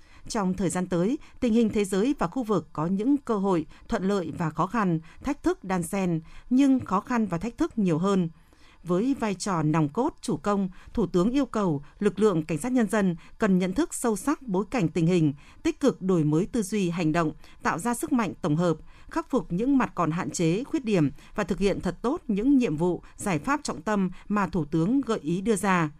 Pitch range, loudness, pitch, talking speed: 170-235 Hz, -26 LUFS, 200 Hz, 230 wpm